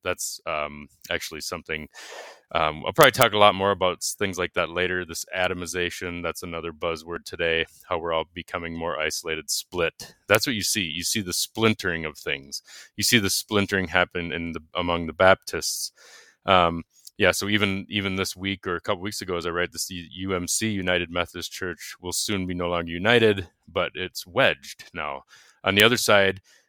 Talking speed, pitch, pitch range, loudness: 185 wpm, 90 Hz, 85-100 Hz, -24 LUFS